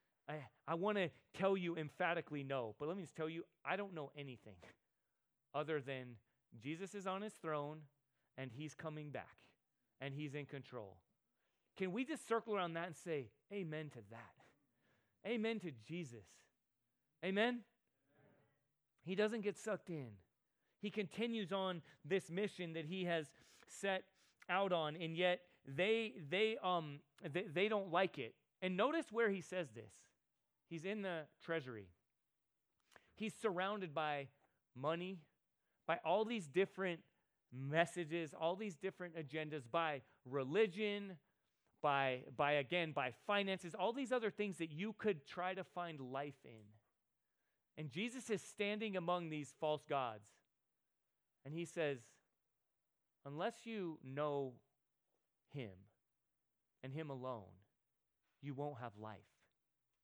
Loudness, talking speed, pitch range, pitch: -43 LUFS, 140 wpm, 140-190 Hz, 165 Hz